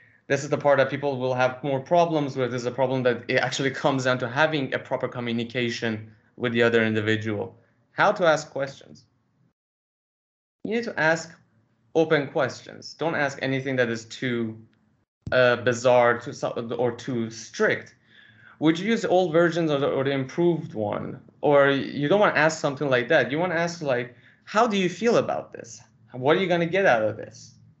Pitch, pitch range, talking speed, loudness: 130 Hz, 120-155 Hz, 195 wpm, -24 LUFS